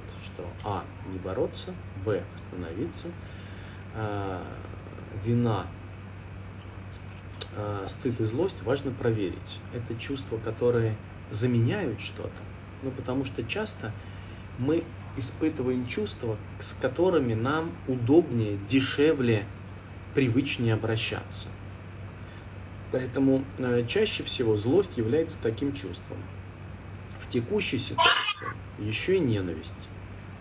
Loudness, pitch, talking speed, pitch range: -29 LUFS, 105 Hz, 95 wpm, 95-120 Hz